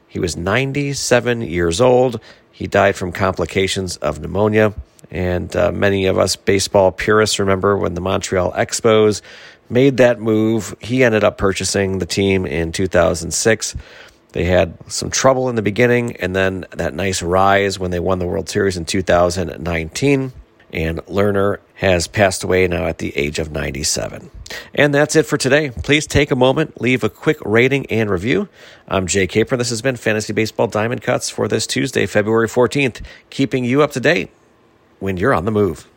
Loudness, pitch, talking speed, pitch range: -17 LUFS, 100 Hz, 175 wpm, 90-120 Hz